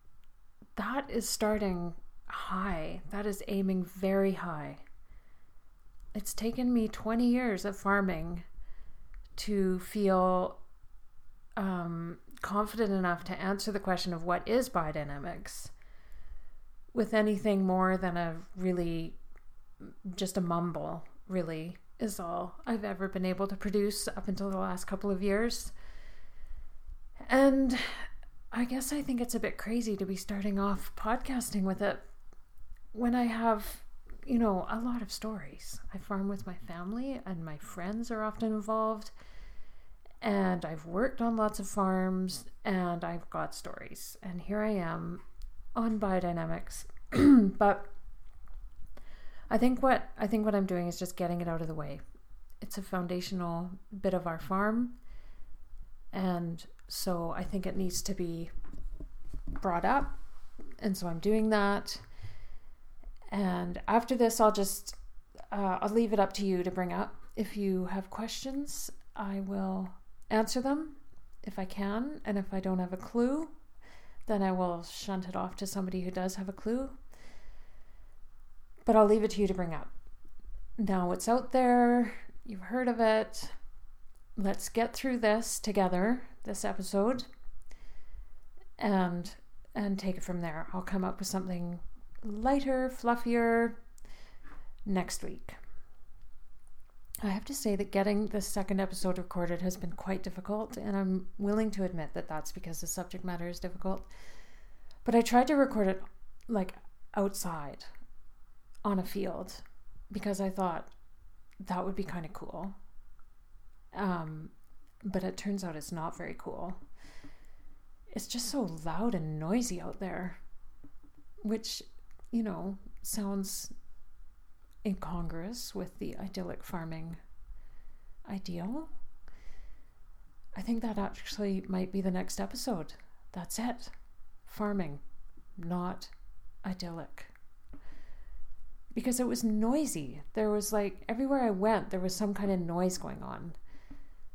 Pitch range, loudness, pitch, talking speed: 180-220 Hz, -33 LUFS, 195 Hz, 140 wpm